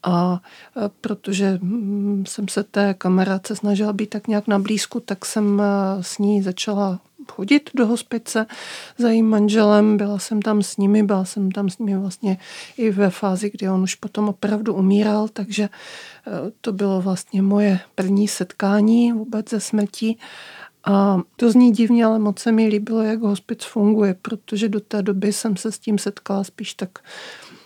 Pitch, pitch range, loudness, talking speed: 210 Hz, 195-220 Hz, -20 LUFS, 165 wpm